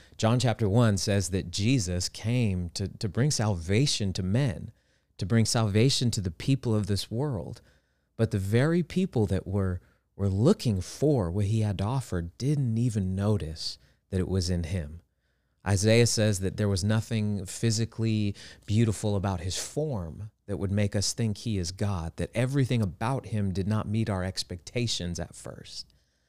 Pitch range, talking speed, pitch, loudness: 95-115 Hz, 165 wpm, 105 Hz, -28 LUFS